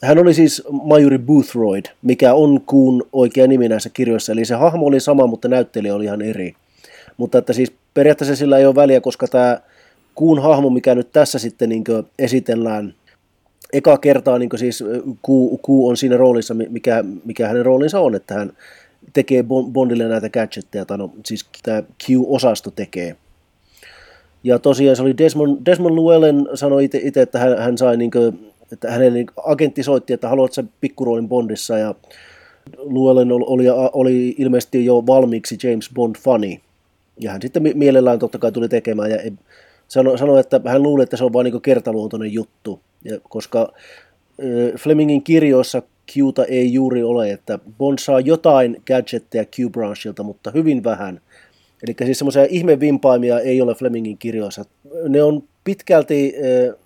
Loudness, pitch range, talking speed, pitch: -16 LUFS, 115-140 Hz, 155 wpm, 125 Hz